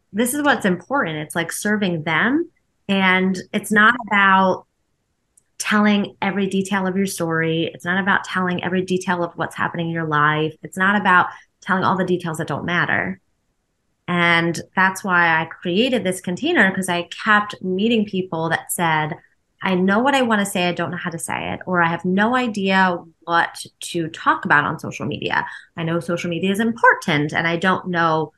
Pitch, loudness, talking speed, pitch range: 185 Hz, -19 LUFS, 190 wpm, 170-200 Hz